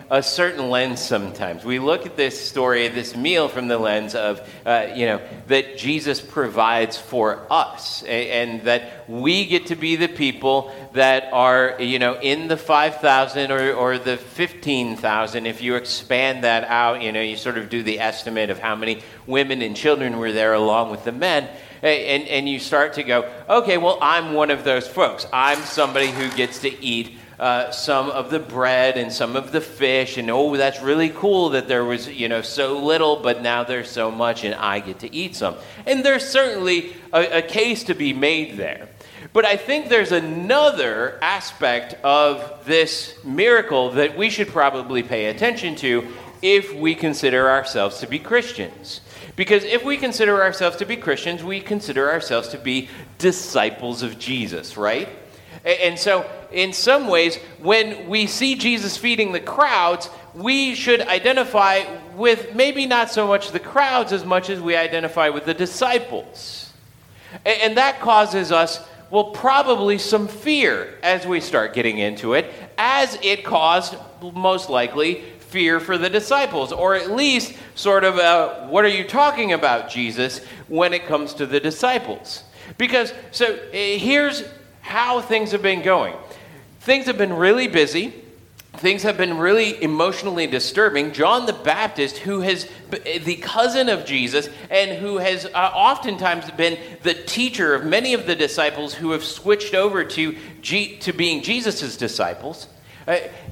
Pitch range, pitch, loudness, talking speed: 130-200 Hz, 160 Hz, -19 LUFS, 170 wpm